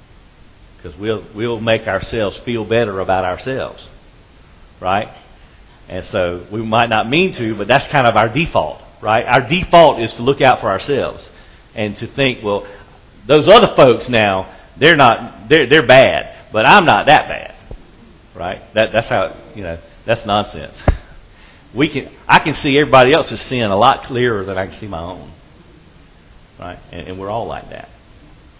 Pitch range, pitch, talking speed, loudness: 95-120 Hz, 110 Hz, 170 wpm, -14 LUFS